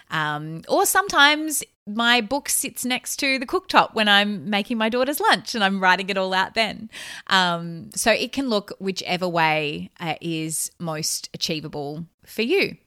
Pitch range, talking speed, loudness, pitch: 165-245 Hz, 170 wpm, -21 LUFS, 200 Hz